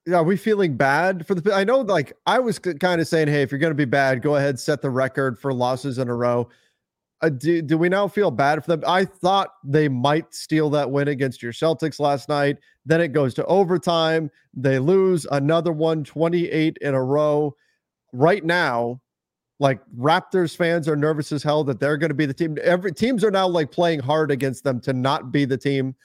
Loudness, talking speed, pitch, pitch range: -21 LUFS, 225 wpm, 155 Hz, 140-170 Hz